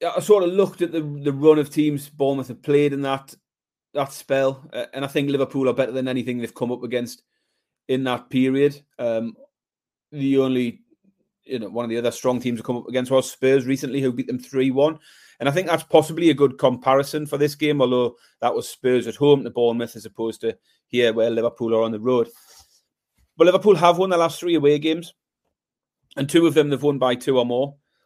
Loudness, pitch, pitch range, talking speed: -21 LUFS, 135 Hz, 125-155 Hz, 220 wpm